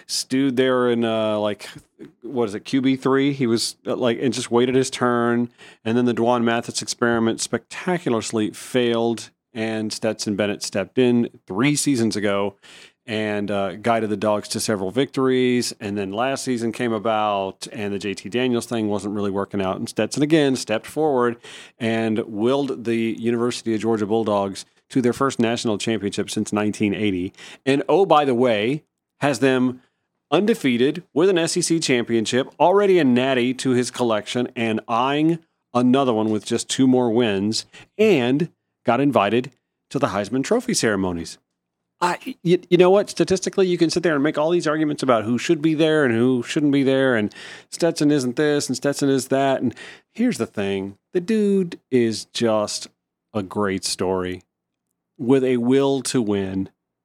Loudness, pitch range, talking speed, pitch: -21 LUFS, 110-135 Hz, 165 wpm, 120 Hz